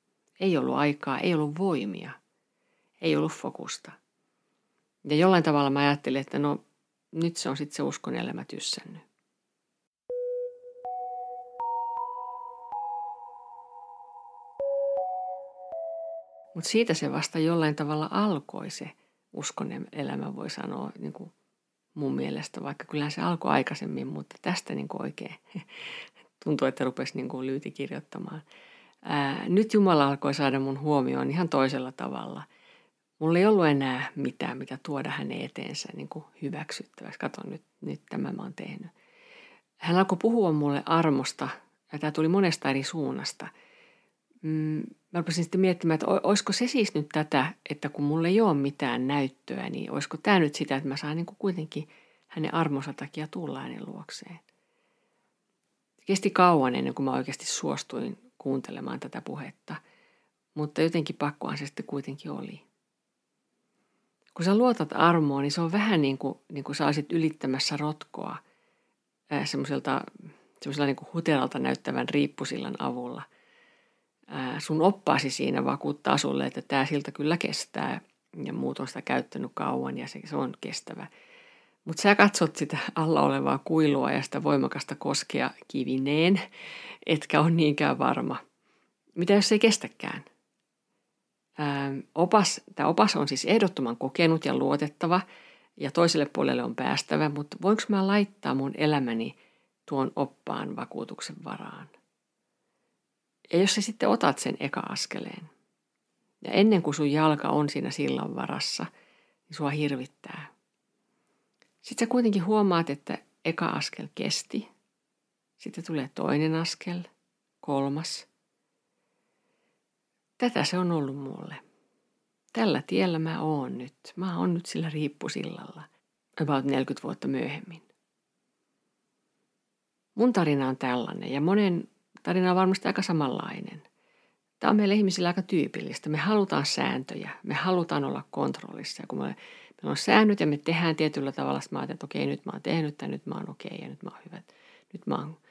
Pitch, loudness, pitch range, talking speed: 160 Hz, -28 LUFS, 140-205 Hz, 140 wpm